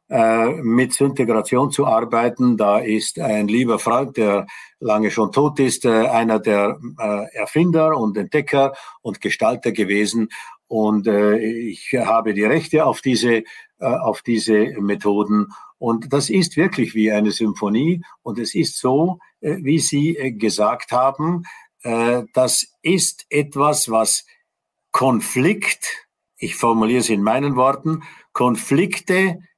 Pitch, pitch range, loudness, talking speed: 120 Hz, 110-150 Hz, -18 LUFS, 120 wpm